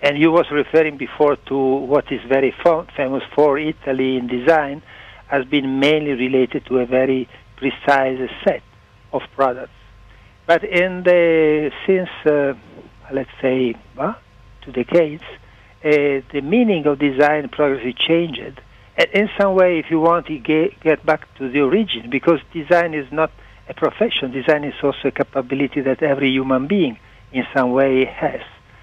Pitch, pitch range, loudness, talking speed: 140 Hz, 130-160 Hz, -18 LUFS, 160 wpm